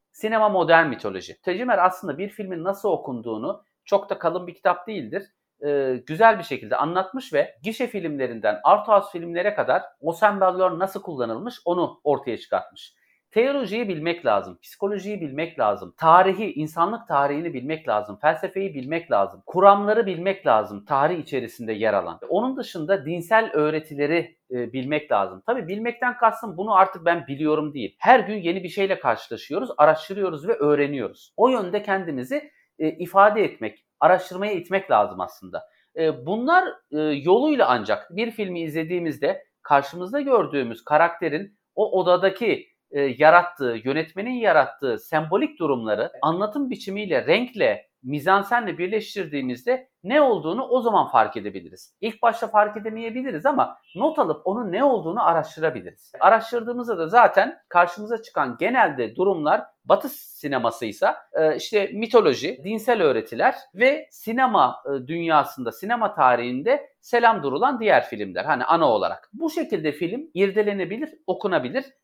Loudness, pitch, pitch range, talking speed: -22 LUFS, 190 Hz, 155-225 Hz, 130 wpm